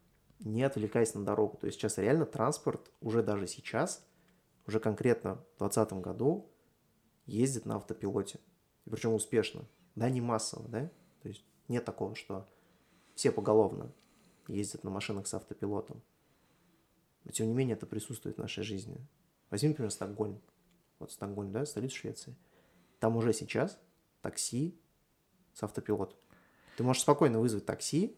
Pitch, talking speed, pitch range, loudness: 110 Hz, 145 wpm, 105-130 Hz, -35 LUFS